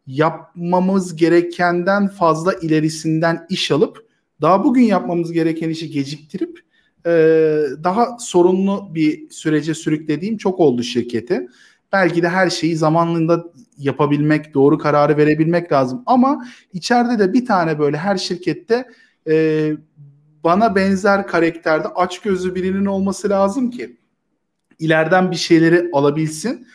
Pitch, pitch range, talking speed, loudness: 170 Hz, 155-195 Hz, 115 wpm, -17 LUFS